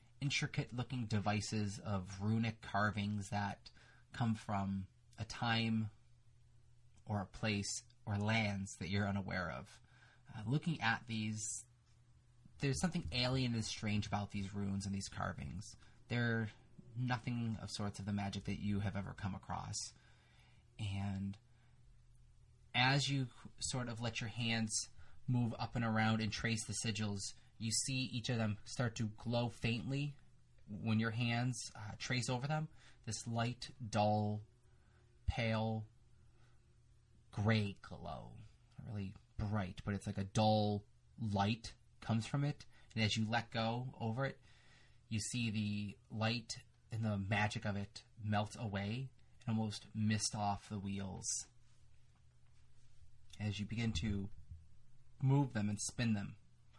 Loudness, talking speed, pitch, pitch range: -40 LUFS, 140 wpm, 110 Hz, 105-120 Hz